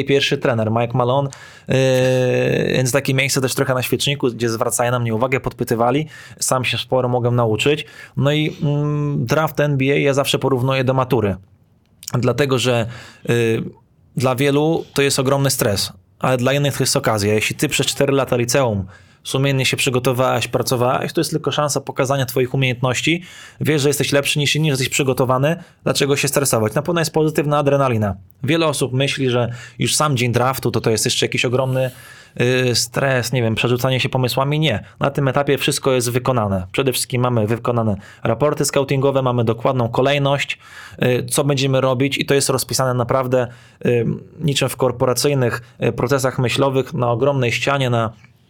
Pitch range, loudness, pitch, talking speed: 120-140 Hz, -18 LUFS, 130 Hz, 165 wpm